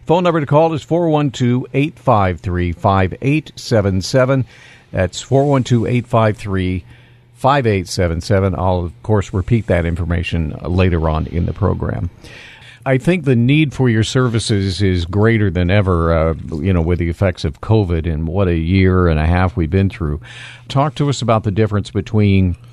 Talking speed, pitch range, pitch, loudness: 155 wpm, 90-125 Hz, 105 Hz, -16 LUFS